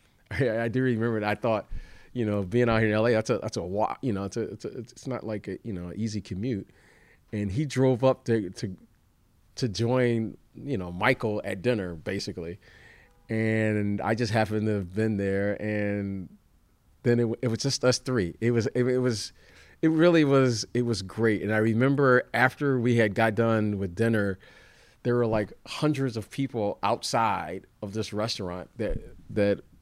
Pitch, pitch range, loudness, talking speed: 110 Hz, 100-120 Hz, -27 LUFS, 190 wpm